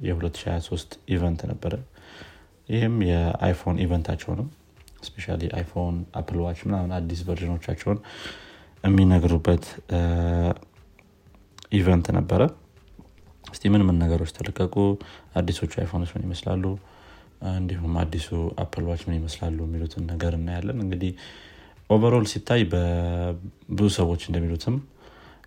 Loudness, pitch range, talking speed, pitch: -25 LUFS, 85-100 Hz, 95 wpm, 90 Hz